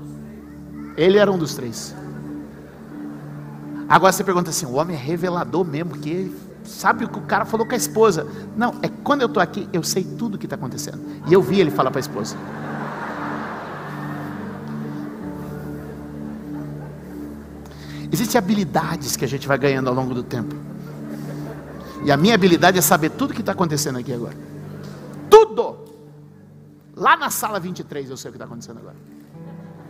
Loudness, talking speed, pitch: -20 LUFS, 165 wpm, 125 Hz